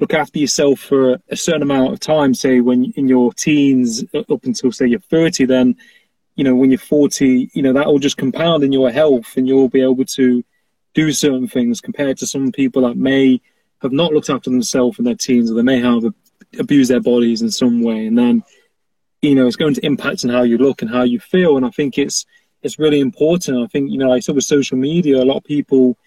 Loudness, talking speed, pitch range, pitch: -15 LUFS, 235 wpm, 125-150 Hz, 135 Hz